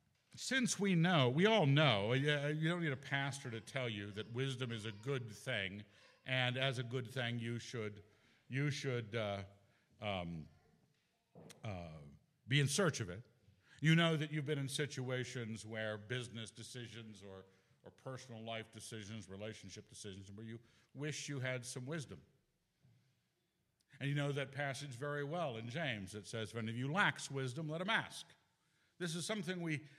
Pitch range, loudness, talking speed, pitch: 110-145 Hz, -39 LUFS, 165 wpm, 125 Hz